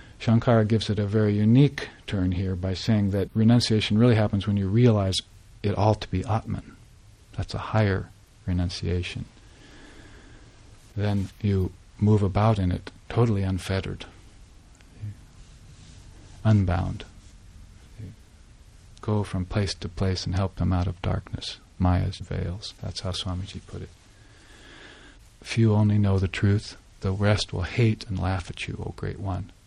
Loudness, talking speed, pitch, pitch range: -25 LUFS, 140 wpm, 100 Hz, 95-105 Hz